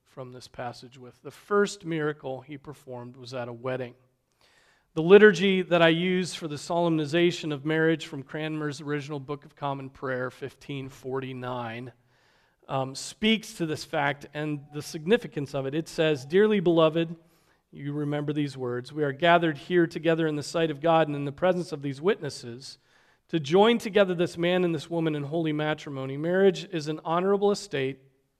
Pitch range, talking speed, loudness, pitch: 135-170 Hz, 175 wpm, -26 LUFS, 150 Hz